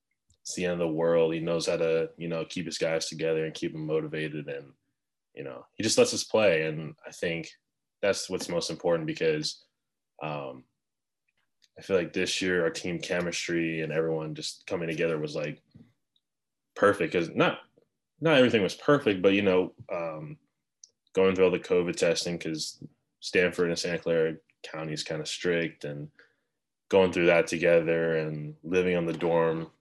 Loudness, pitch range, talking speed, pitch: -28 LUFS, 80-90 Hz, 180 wpm, 85 Hz